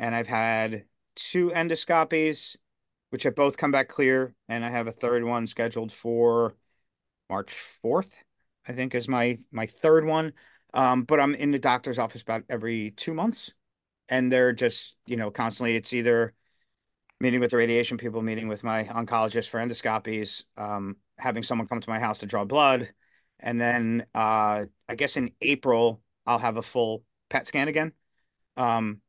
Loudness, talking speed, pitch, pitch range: -26 LUFS, 170 wpm, 115 Hz, 110-130 Hz